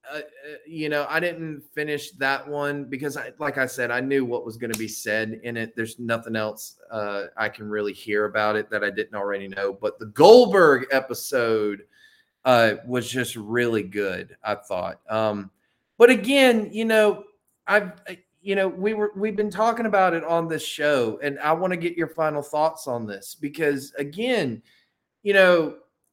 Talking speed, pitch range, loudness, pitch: 185 wpm, 115-185 Hz, -23 LUFS, 145 Hz